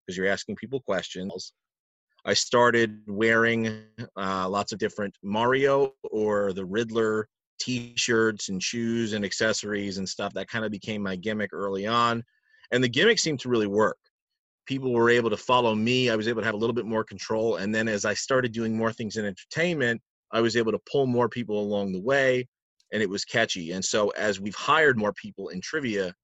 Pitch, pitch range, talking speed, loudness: 110 Hz, 105-120 Hz, 200 wpm, -26 LUFS